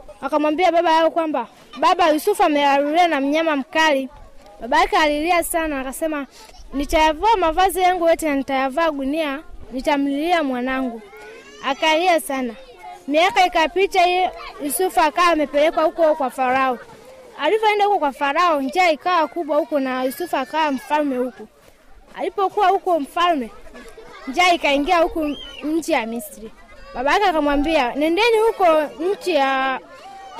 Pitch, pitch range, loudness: 315 Hz, 280-350 Hz, -19 LUFS